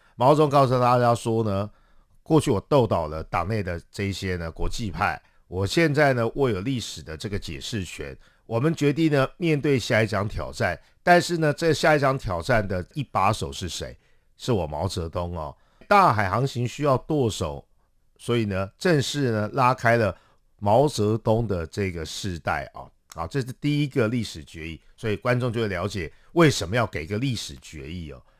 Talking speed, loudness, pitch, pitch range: 265 characters per minute, -24 LUFS, 110 Hz, 90-135 Hz